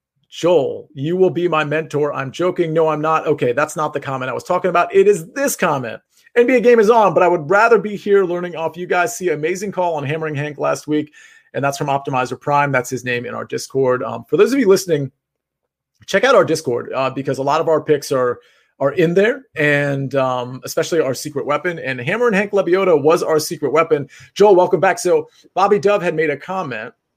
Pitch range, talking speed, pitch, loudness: 140-190 Hz, 225 wpm, 160 Hz, -17 LUFS